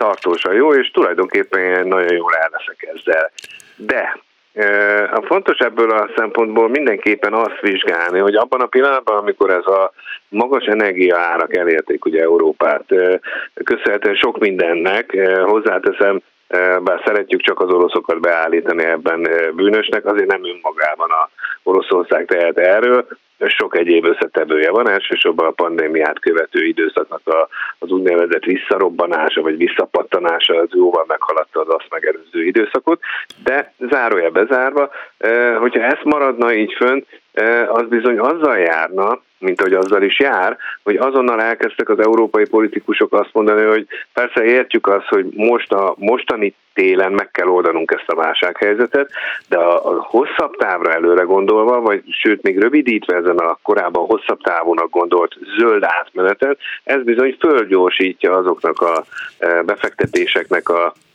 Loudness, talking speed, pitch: -15 LUFS, 140 wpm, 350 Hz